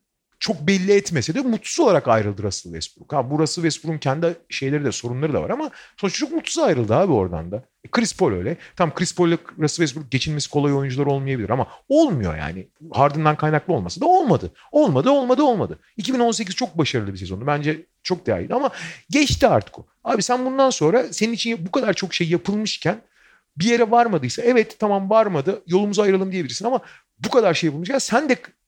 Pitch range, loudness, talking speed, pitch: 150-230 Hz, -20 LUFS, 190 wpm, 175 Hz